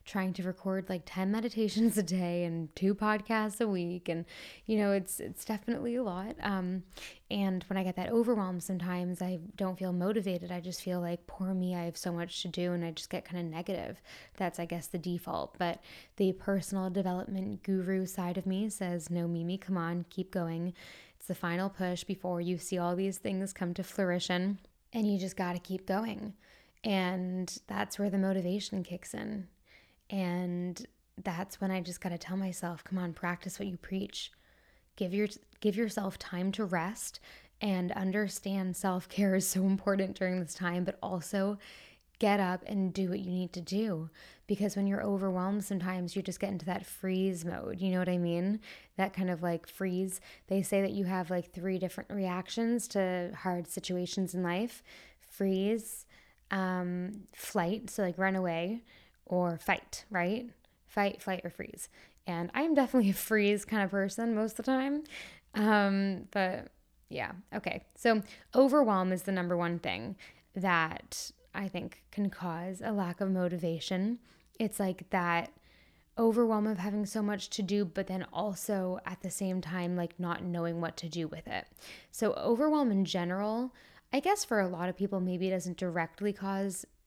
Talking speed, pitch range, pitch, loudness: 185 wpm, 180-205 Hz, 190 Hz, -34 LUFS